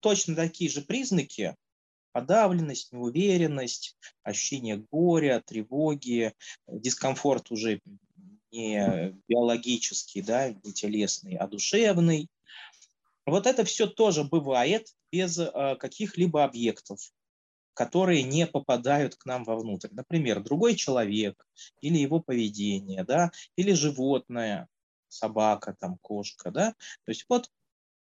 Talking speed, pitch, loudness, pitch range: 105 wpm, 140 Hz, -28 LUFS, 110-175 Hz